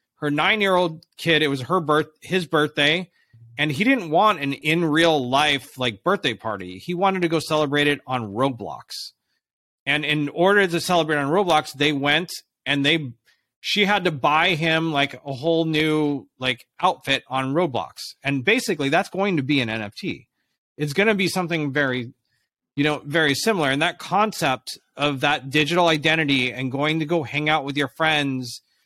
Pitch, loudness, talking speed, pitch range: 150 Hz, -21 LUFS, 180 wpm, 140-170 Hz